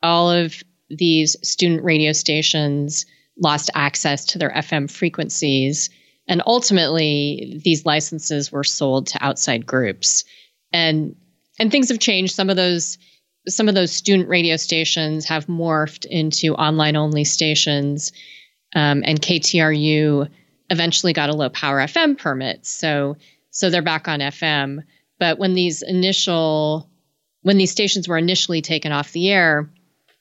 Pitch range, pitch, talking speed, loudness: 150-175 Hz, 160 Hz, 140 wpm, -18 LUFS